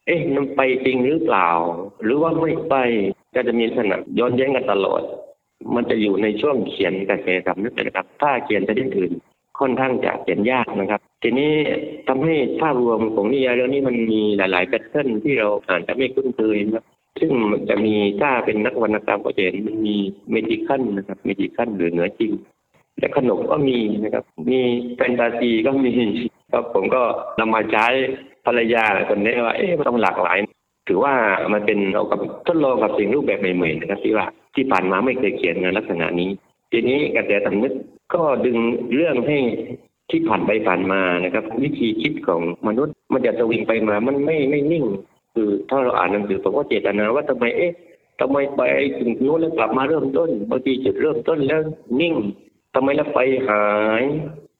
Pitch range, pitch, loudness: 105-135 Hz, 120 Hz, -20 LUFS